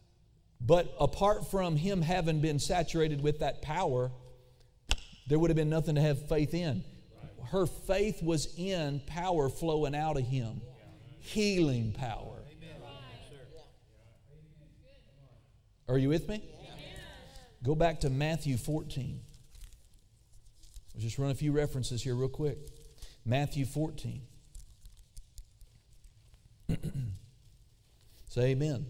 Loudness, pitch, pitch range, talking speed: -32 LUFS, 140 Hz, 125-155 Hz, 110 wpm